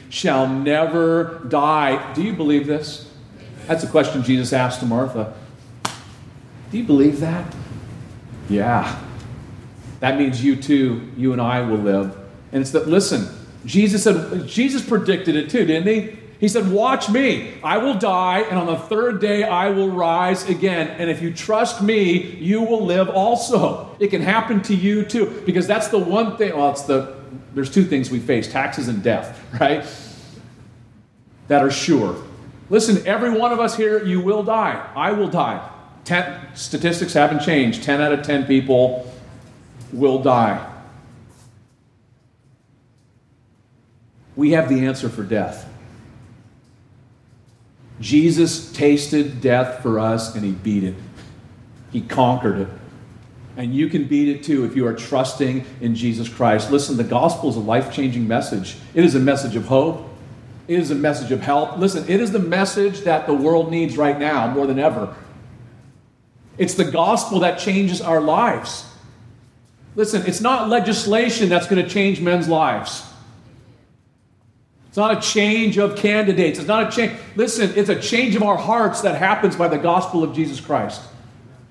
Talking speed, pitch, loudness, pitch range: 160 wpm, 140 Hz, -19 LUFS, 125-185 Hz